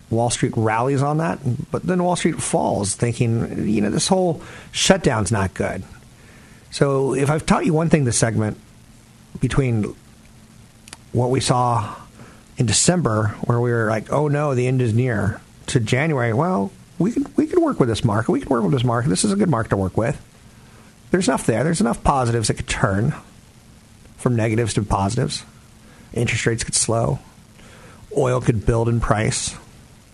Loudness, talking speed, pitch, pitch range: -20 LUFS, 180 wpm, 120 Hz, 115-145 Hz